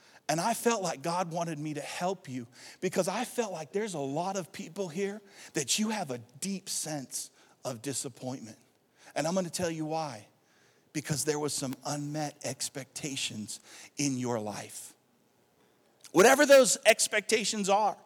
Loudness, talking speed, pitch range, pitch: -30 LUFS, 160 wpm, 140-200 Hz, 165 Hz